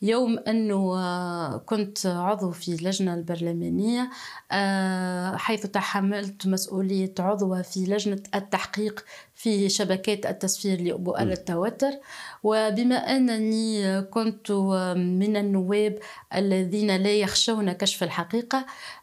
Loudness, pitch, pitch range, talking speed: -26 LUFS, 200 Hz, 185-215 Hz, 95 wpm